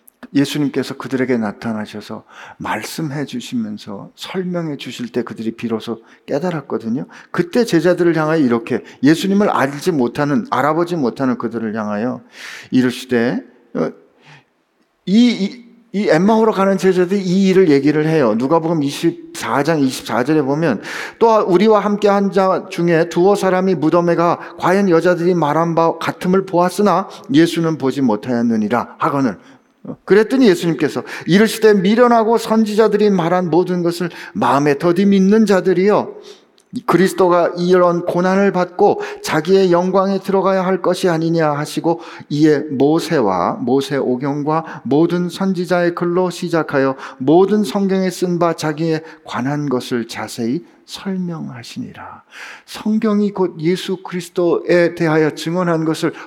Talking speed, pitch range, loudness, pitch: 310 characters per minute, 145-195 Hz, -16 LUFS, 175 Hz